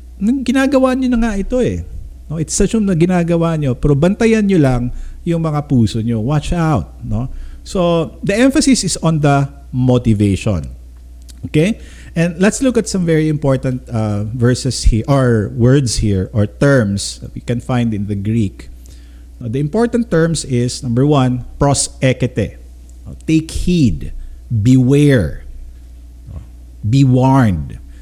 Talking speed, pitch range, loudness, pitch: 145 wpm, 105-165 Hz, -15 LUFS, 130 Hz